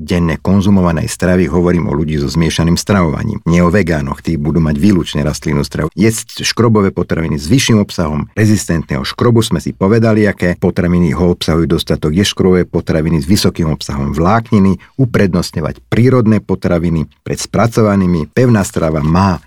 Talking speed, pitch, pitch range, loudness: 150 wpm, 90 Hz, 80-105 Hz, -13 LUFS